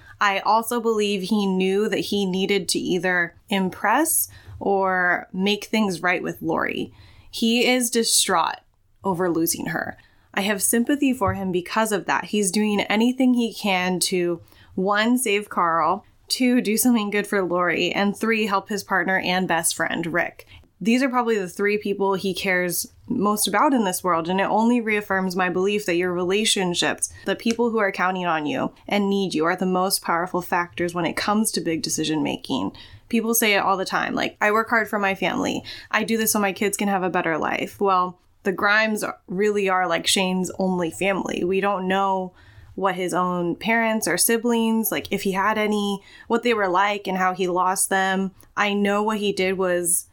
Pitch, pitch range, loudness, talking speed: 195 Hz, 185-215 Hz, -22 LUFS, 195 wpm